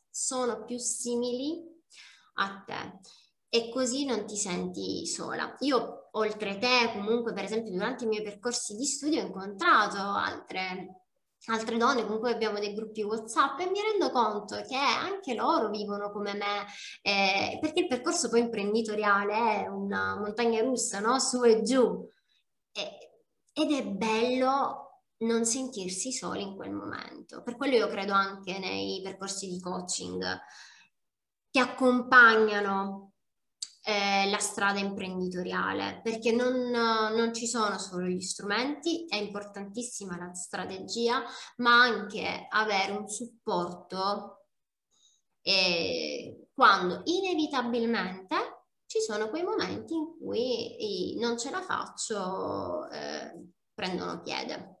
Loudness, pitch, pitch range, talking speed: -29 LUFS, 225 Hz, 200-250 Hz, 125 wpm